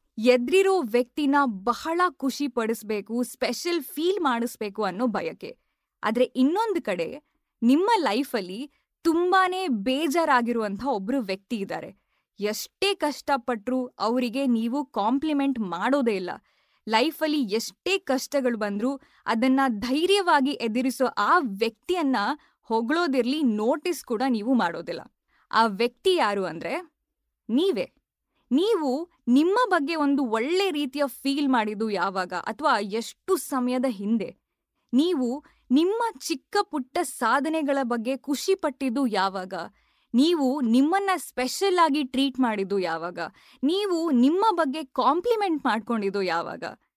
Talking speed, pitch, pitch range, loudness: 105 wpm, 265 Hz, 230-315 Hz, -25 LUFS